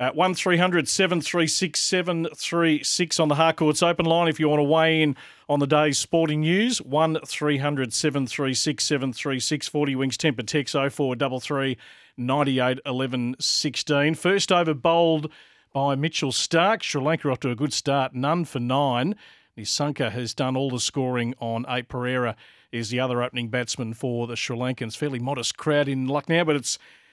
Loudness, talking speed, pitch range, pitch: -23 LUFS, 170 wpm, 130-160 Hz, 145 Hz